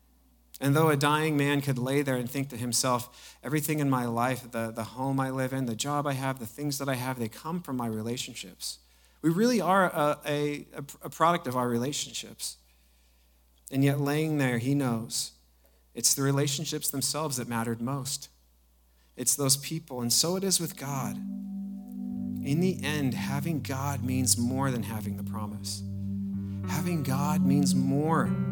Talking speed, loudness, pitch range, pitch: 175 wpm, -29 LUFS, 105-145 Hz, 130 Hz